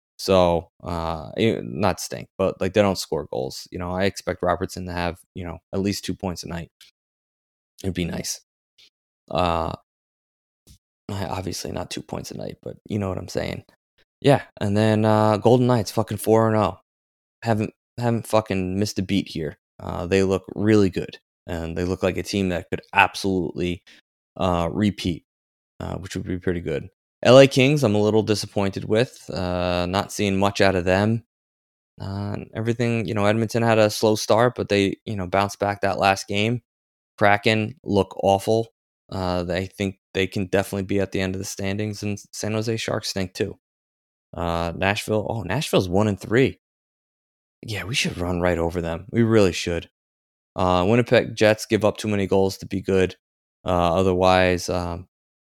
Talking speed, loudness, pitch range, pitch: 175 wpm, -22 LUFS, 90-105 Hz, 95 Hz